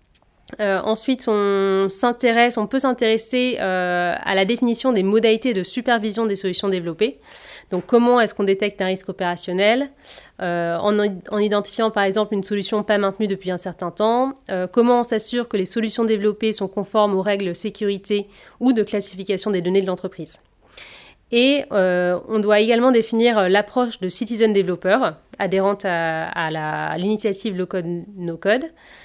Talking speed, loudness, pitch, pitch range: 165 wpm, -20 LUFS, 205 Hz, 190-230 Hz